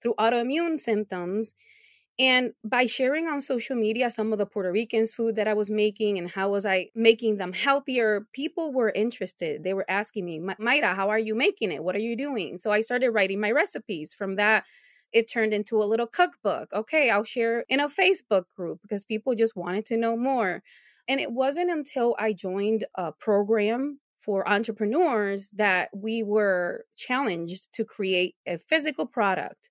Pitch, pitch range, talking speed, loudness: 220 Hz, 200-255 Hz, 180 wpm, -26 LUFS